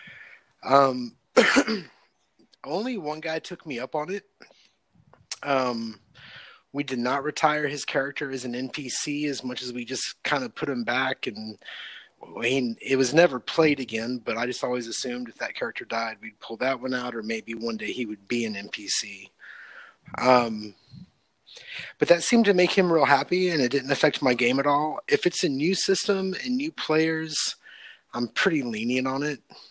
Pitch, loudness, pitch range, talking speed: 135 Hz, -25 LUFS, 125-160 Hz, 180 wpm